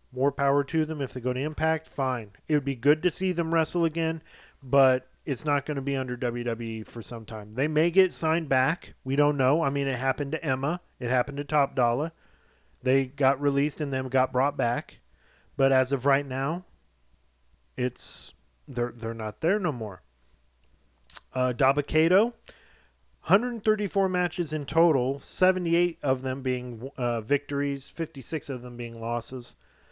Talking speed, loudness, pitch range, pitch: 170 wpm, -27 LUFS, 125-155 Hz, 135 Hz